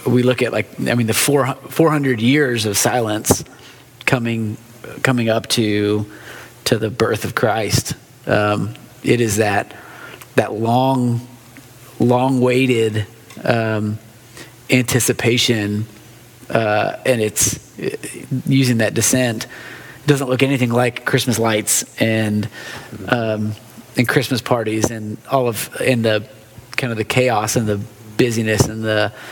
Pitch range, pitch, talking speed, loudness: 110-125 Hz, 120 Hz, 130 wpm, -18 LUFS